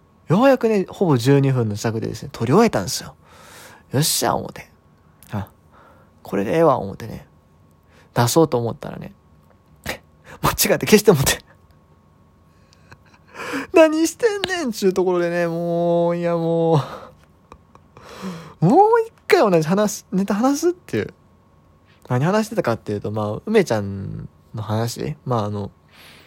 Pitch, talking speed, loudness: 140 Hz, 270 characters per minute, -19 LUFS